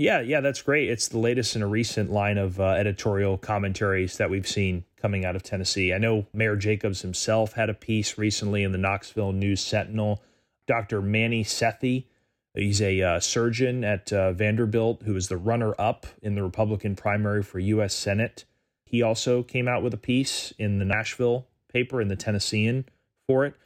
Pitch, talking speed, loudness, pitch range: 105 Hz, 185 wpm, -26 LUFS, 100-115 Hz